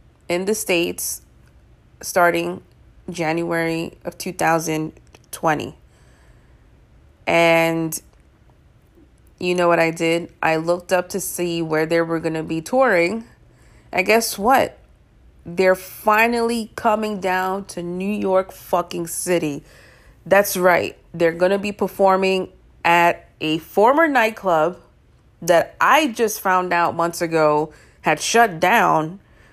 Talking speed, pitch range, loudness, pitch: 115 wpm, 165-190 Hz, -19 LUFS, 175 Hz